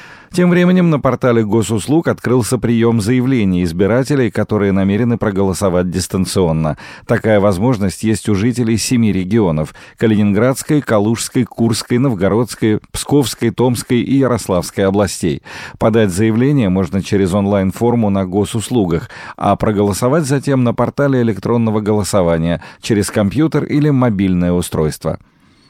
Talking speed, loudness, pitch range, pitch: 110 wpm, -15 LUFS, 100-125 Hz, 110 Hz